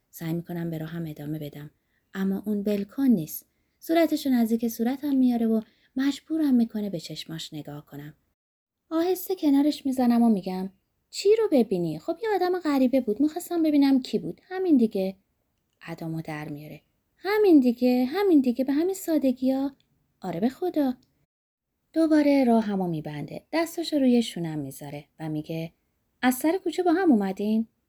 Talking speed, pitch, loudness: 155 wpm, 240 Hz, -25 LUFS